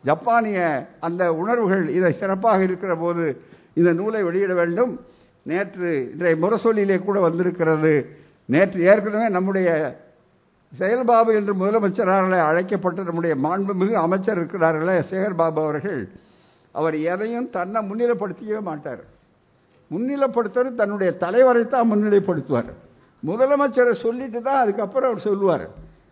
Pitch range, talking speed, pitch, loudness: 170-225 Hz, 105 wpm, 195 Hz, -21 LUFS